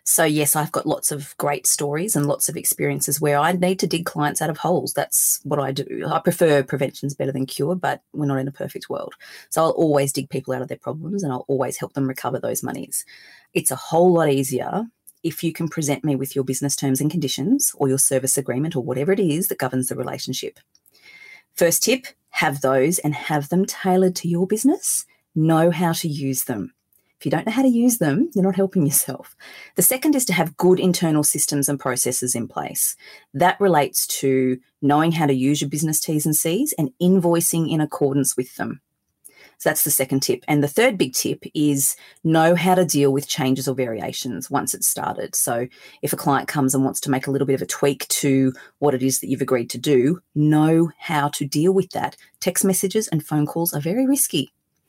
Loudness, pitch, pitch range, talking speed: -20 LUFS, 150 Hz, 140-175 Hz, 220 wpm